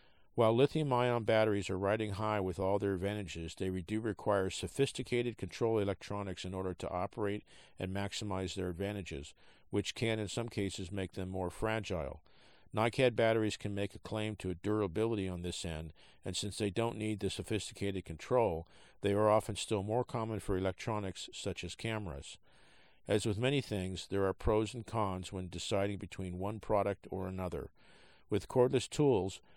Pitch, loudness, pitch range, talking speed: 100 Hz, -36 LUFS, 95-110 Hz, 170 wpm